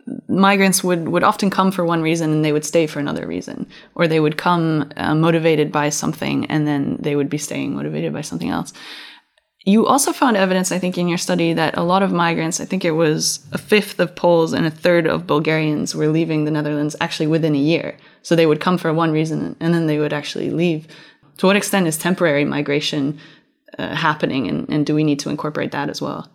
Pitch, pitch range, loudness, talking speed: 165 Hz, 150-180 Hz, -18 LUFS, 225 wpm